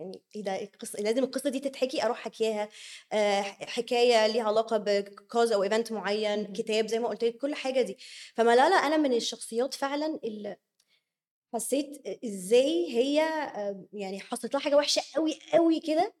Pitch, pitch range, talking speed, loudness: 230 Hz, 210-275 Hz, 150 wpm, -28 LUFS